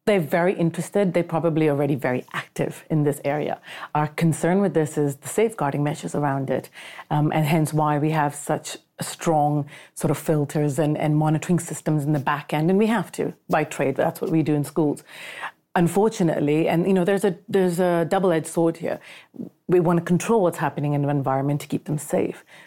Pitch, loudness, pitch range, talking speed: 155 Hz, -23 LUFS, 150-175 Hz, 205 wpm